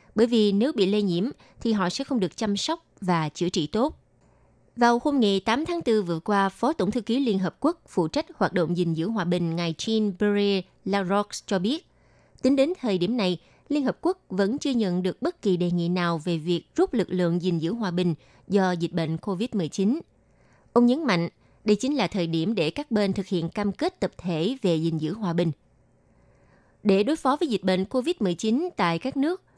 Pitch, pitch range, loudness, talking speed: 200 Hz, 175-240 Hz, -25 LUFS, 215 wpm